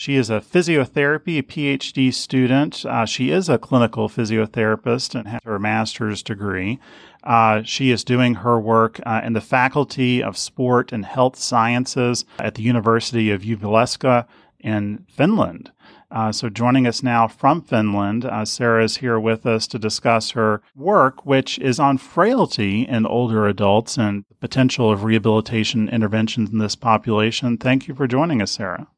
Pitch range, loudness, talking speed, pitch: 110-130 Hz, -19 LUFS, 160 wpm, 115 Hz